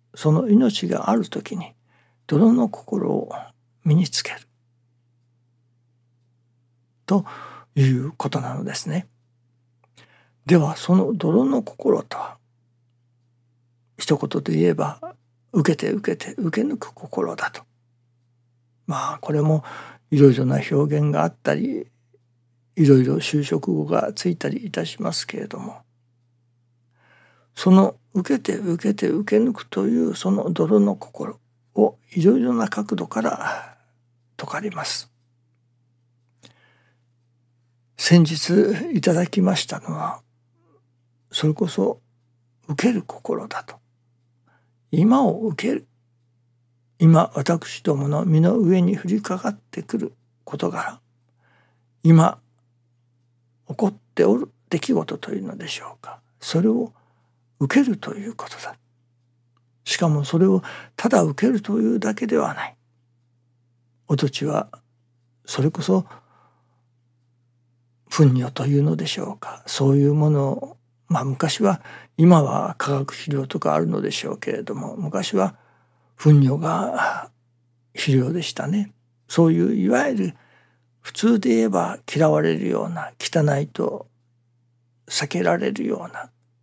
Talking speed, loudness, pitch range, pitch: 220 characters per minute, -21 LUFS, 120-170 Hz, 120 Hz